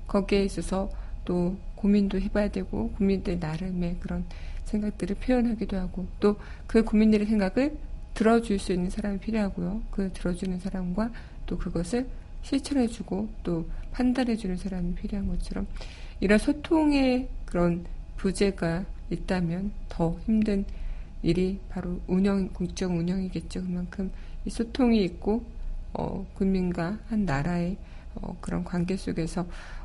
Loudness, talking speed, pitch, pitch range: -28 LUFS, 290 characters per minute, 195 Hz, 180-210 Hz